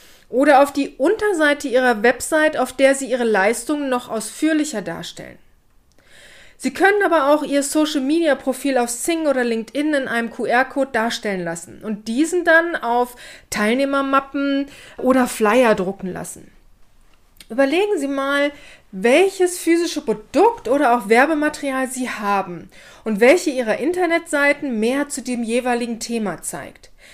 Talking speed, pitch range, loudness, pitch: 130 wpm, 235-295 Hz, -18 LUFS, 270 Hz